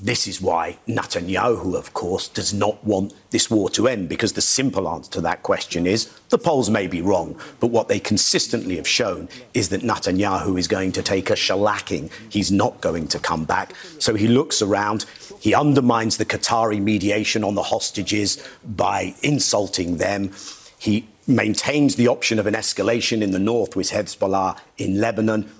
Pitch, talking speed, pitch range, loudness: 105 Hz, 180 wpm, 100-115 Hz, -20 LUFS